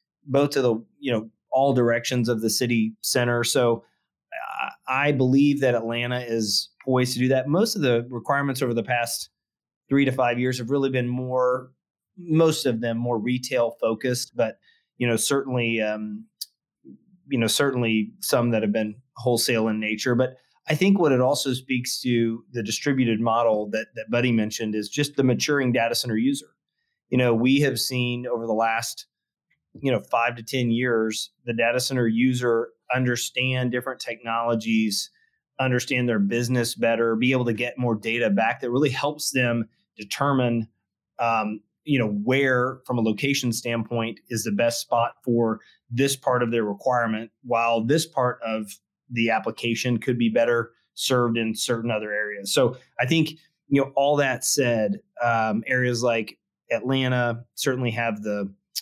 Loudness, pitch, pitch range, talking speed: -24 LUFS, 120 Hz, 115-130 Hz, 165 wpm